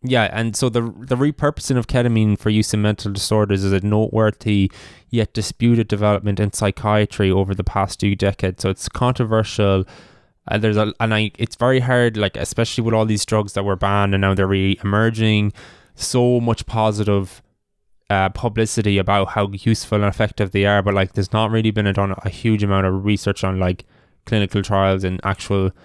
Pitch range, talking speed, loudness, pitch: 100-110 Hz, 190 wpm, -19 LUFS, 105 Hz